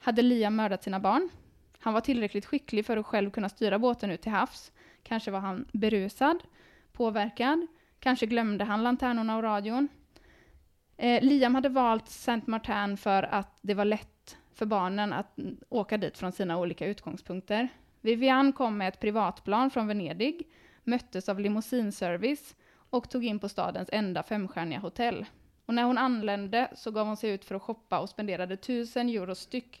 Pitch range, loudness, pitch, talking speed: 200-245 Hz, -30 LUFS, 220 Hz, 170 wpm